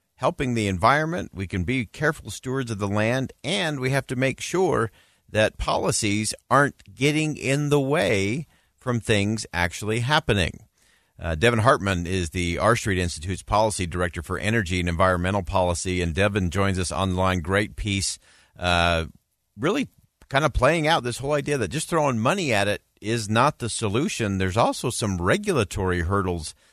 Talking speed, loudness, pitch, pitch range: 165 wpm, -24 LUFS, 105 Hz, 95-130 Hz